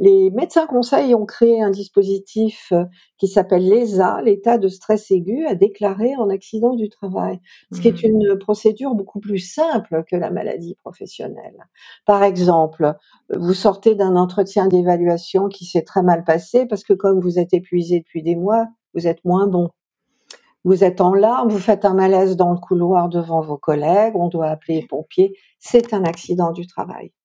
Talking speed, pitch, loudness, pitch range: 180 wpm, 195 Hz, -17 LUFS, 175-220 Hz